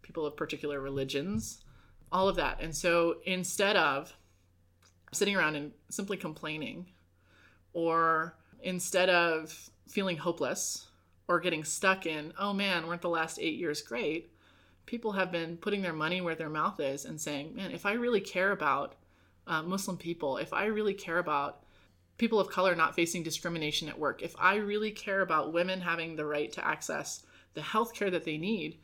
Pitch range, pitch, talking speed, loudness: 150-190 Hz, 165 Hz, 175 wpm, -32 LUFS